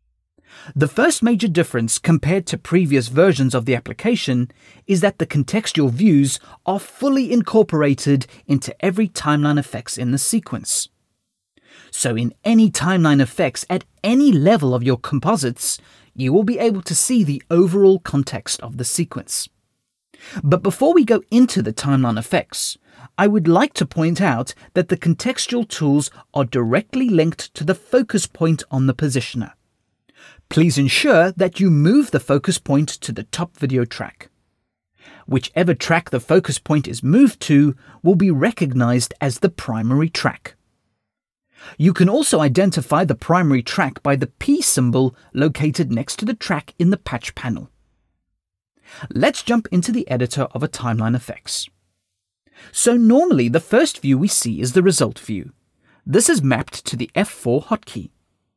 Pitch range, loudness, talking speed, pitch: 130-190 Hz, -18 LUFS, 155 wpm, 155 Hz